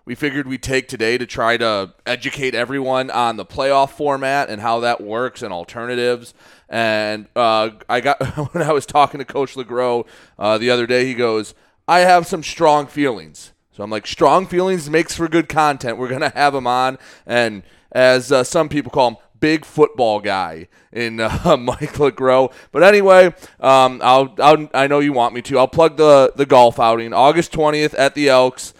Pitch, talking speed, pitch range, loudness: 130 Hz, 190 wpm, 120-145 Hz, -16 LUFS